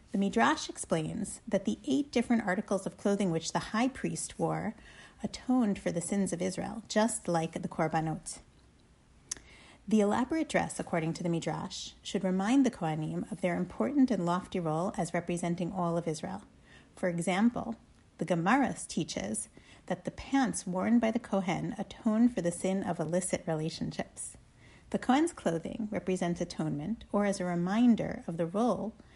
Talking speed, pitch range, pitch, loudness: 160 wpm, 175-220 Hz, 190 Hz, -32 LUFS